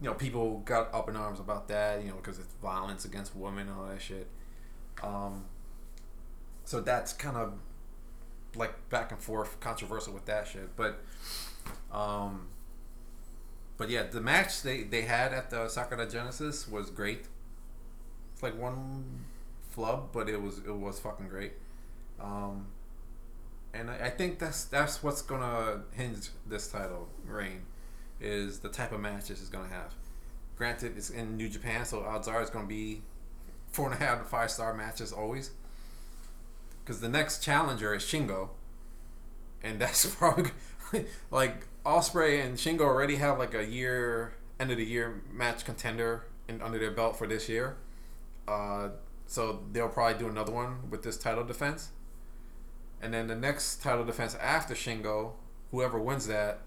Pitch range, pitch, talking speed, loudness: 105-120 Hz, 115 Hz, 165 wpm, -34 LUFS